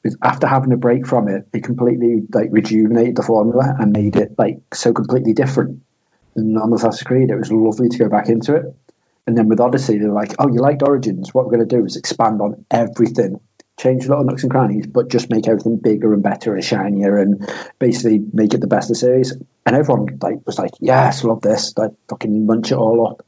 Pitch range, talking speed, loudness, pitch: 110-125 Hz, 230 wpm, -16 LUFS, 115 Hz